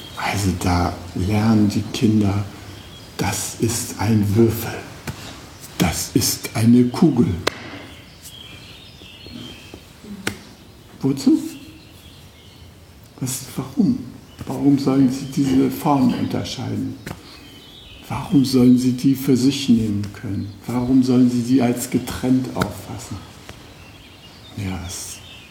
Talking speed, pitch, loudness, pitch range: 95 wpm, 115 Hz, -19 LUFS, 100-130 Hz